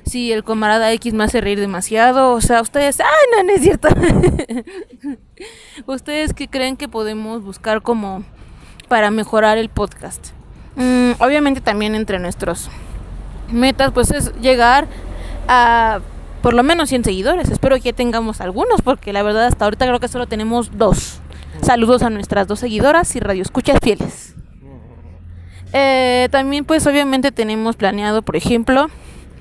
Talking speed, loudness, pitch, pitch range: 155 wpm, -15 LUFS, 235 Hz, 215-265 Hz